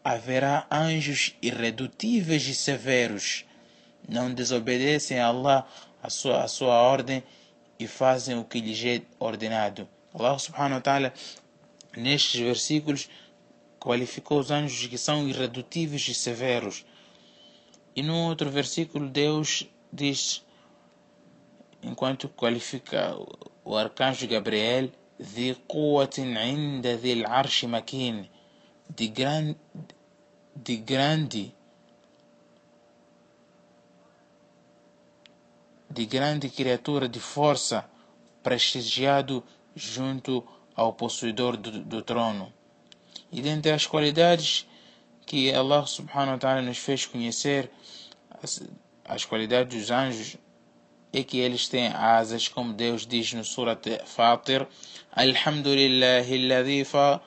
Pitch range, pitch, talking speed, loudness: 120-140 Hz, 130 Hz, 100 wpm, -26 LUFS